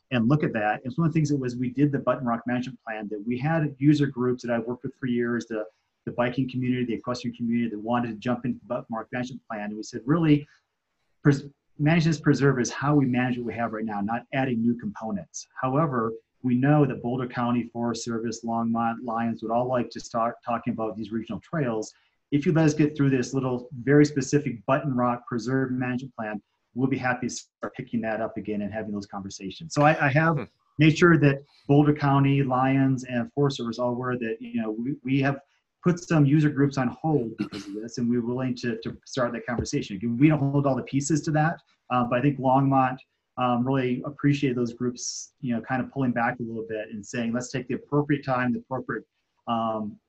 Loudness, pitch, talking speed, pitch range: -26 LUFS, 125 Hz, 230 wpm, 115-140 Hz